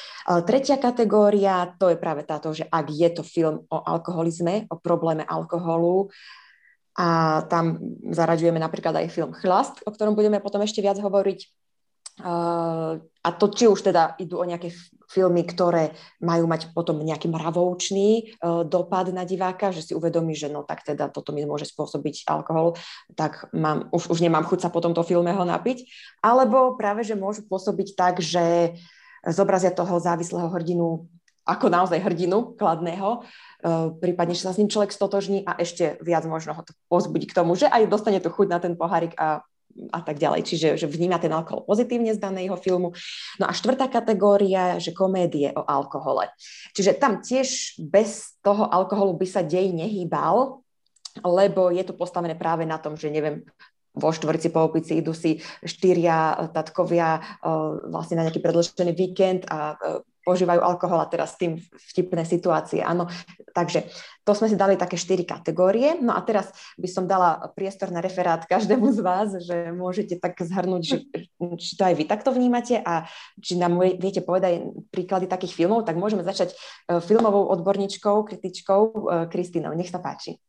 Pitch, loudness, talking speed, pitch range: 180 Hz, -23 LUFS, 170 wpm, 165-200 Hz